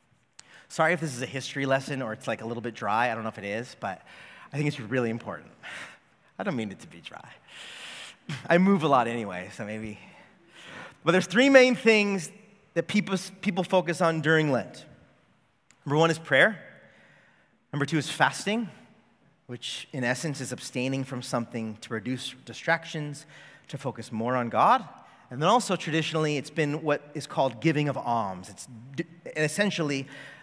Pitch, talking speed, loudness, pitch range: 145 Hz, 175 wpm, -27 LUFS, 125-170 Hz